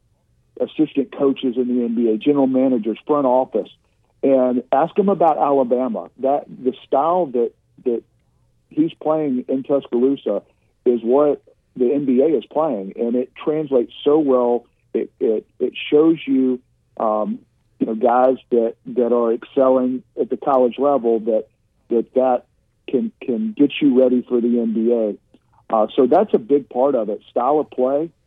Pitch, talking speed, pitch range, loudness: 130 Hz, 155 wpm, 120-145 Hz, -19 LUFS